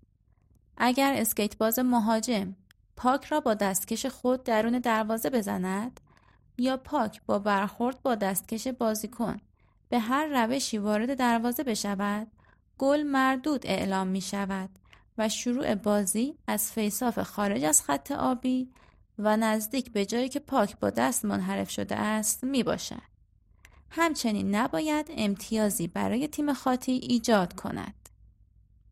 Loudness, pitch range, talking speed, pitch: -28 LUFS, 200-255 Hz, 125 wpm, 225 Hz